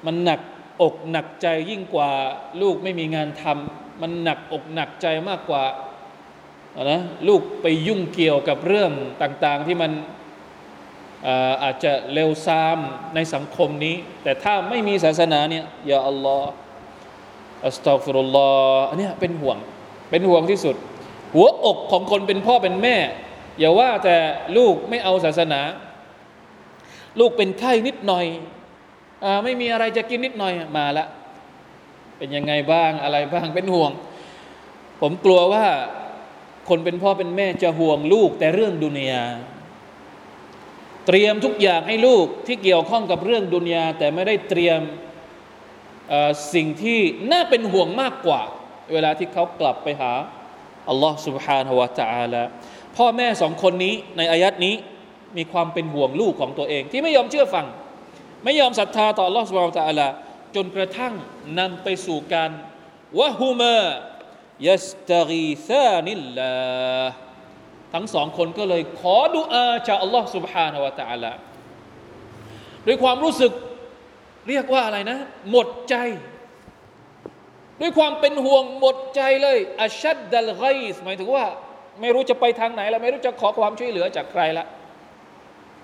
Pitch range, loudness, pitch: 155-230 Hz, -20 LUFS, 180 Hz